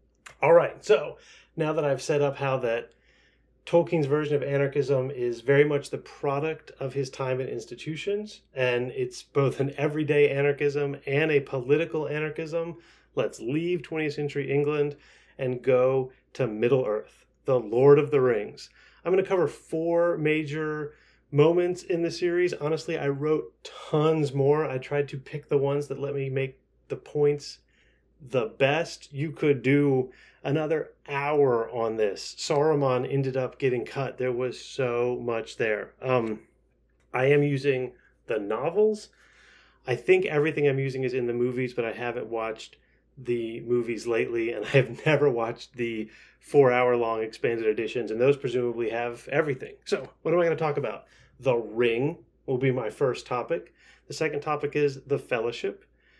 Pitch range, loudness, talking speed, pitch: 125-155 Hz, -26 LUFS, 165 wpm, 140 Hz